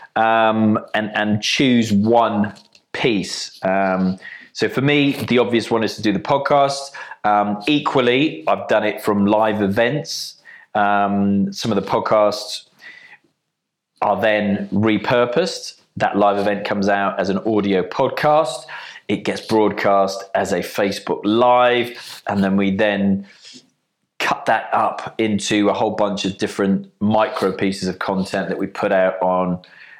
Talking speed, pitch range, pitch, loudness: 145 wpm, 100-115 Hz, 105 Hz, -18 LUFS